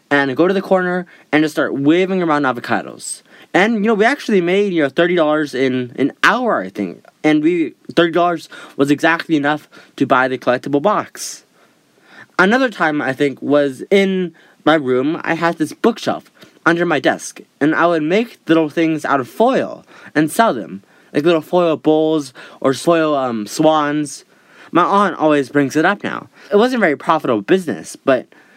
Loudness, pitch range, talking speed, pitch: -16 LUFS, 145-185 Hz, 185 wpm, 160 Hz